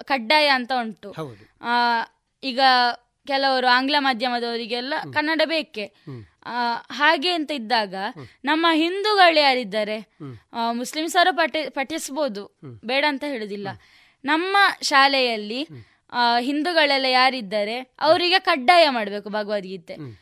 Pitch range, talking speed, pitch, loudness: 220-305 Hz, 95 wpm, 260 Hz, -20 LUFS